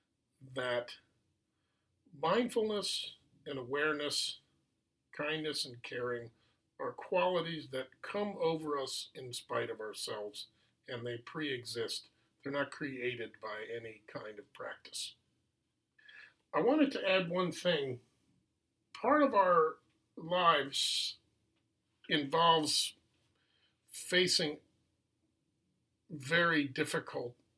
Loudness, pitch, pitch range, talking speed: -34 LUFS, 140 Hz, 115-165 Hz, 95 wpm